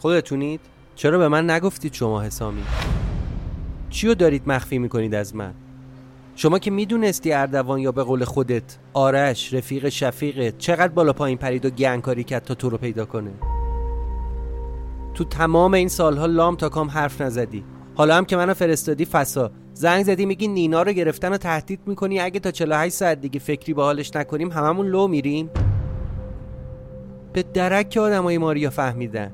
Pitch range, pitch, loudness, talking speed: 120-170 Hz, 140 Hz, -21 LUFS, 160 wpm